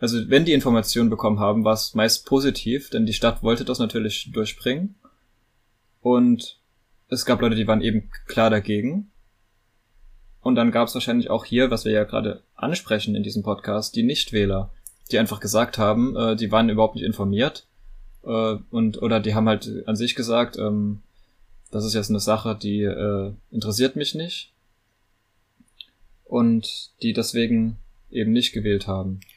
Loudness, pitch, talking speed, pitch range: -22 LUFS, 110 Hz, 165 wpm, 105-120 Hz